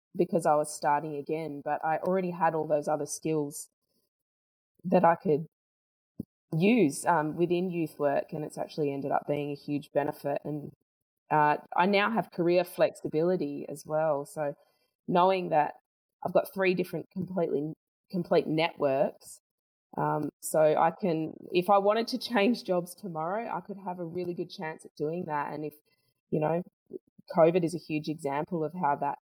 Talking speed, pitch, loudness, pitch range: 170 wpm, 160 Hz, -29 LUFS, 150-180 Hz